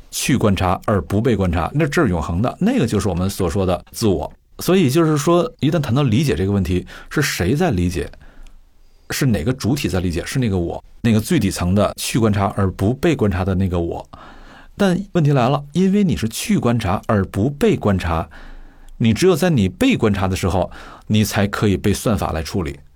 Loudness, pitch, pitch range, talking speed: -18 LUFS, 100 Hz, 90-130 Hz, 295 characters per minute